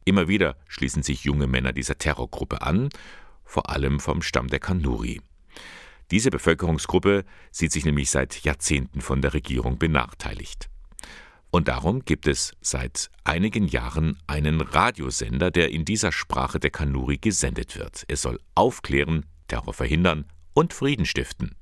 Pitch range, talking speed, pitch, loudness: 70-85 Hz, 140 wpm, 75 Hz, -24 LUFS